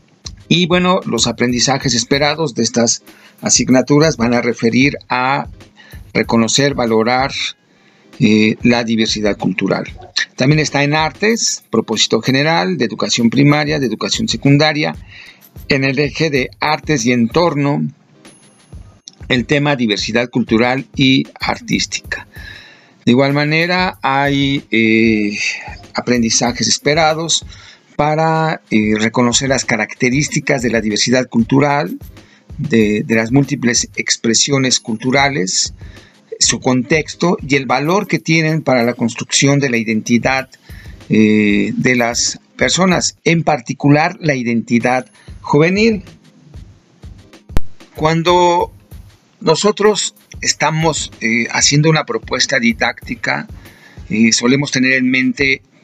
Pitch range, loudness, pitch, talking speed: 115-150 Hz, -14 LUFS, 130 Hz, 105 wpm